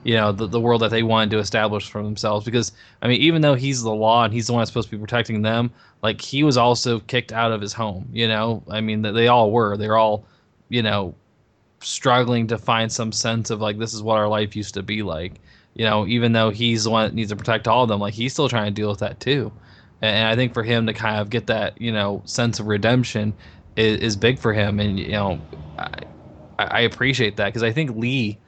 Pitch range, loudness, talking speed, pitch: 105-120 Hz, -20 LUFS, 255 wpm, 110 Hz